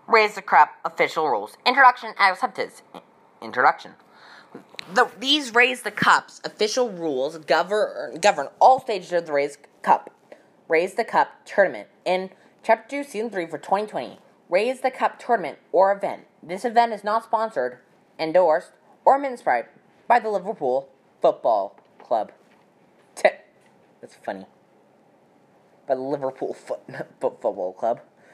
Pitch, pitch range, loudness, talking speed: 210 Hz, 175-240 Hz, -22 LUFS, 125 wpm